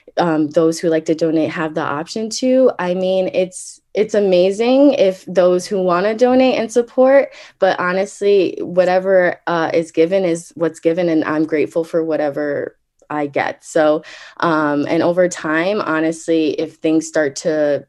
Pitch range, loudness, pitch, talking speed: 160-195 Hz, -16 LUFS, 170 Hz, 165 wpm